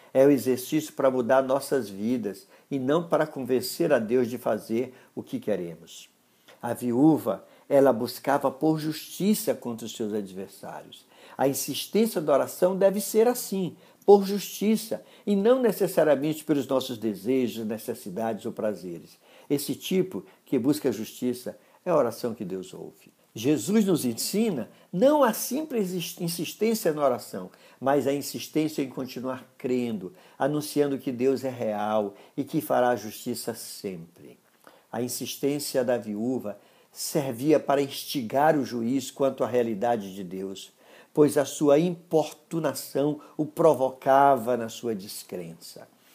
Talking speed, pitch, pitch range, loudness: 140 wpm, 135 Hz, 120-155 Hz, -26 LUFS